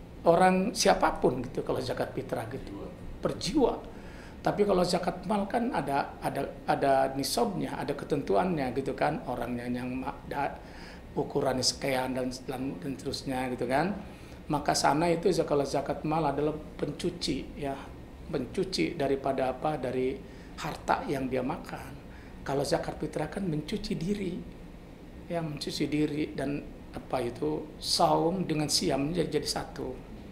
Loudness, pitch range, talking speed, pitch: -30 LUFS, 135-170 Hz, 130 wpm, 150 Hz